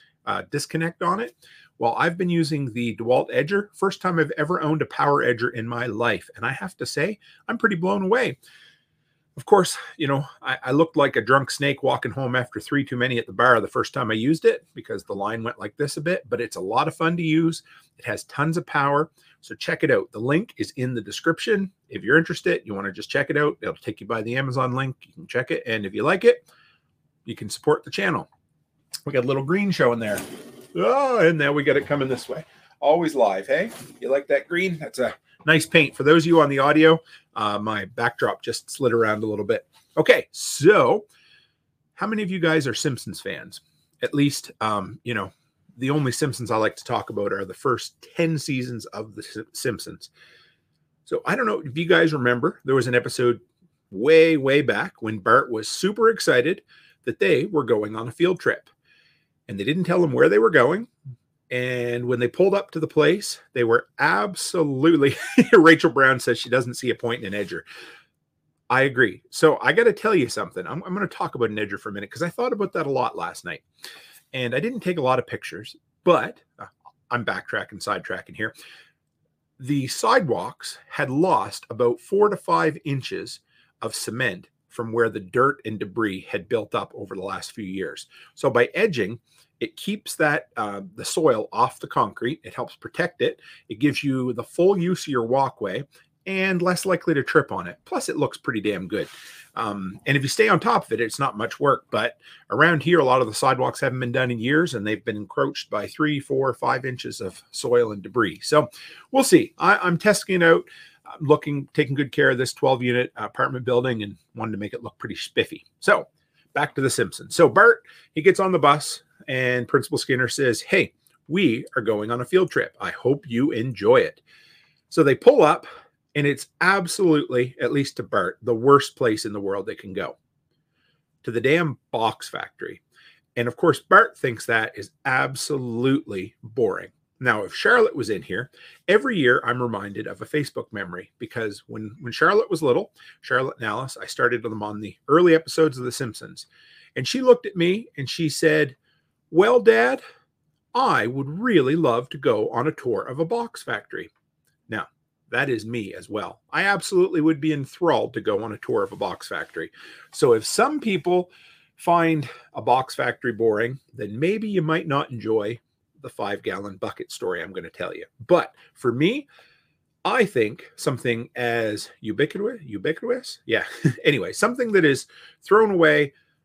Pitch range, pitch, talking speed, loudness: 125-185 Hz, 150 Hz, 205 wpm, -22 LUFS